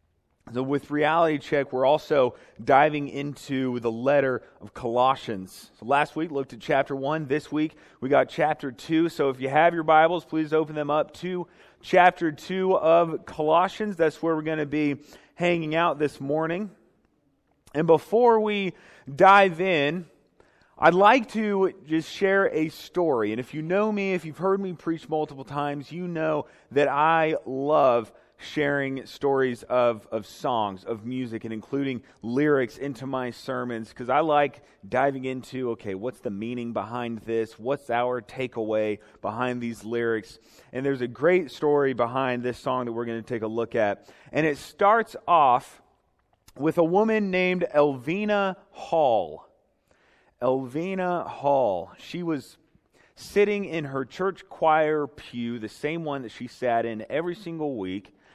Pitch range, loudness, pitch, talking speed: 125-165 Hz, -25 LUFS, 145 Hz, 160 wpm